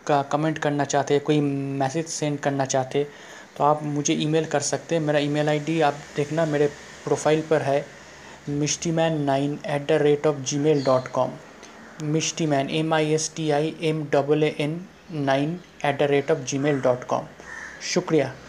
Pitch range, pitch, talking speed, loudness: 145-155 Hz, 150 Hz, 180 wpm, -24 LUFS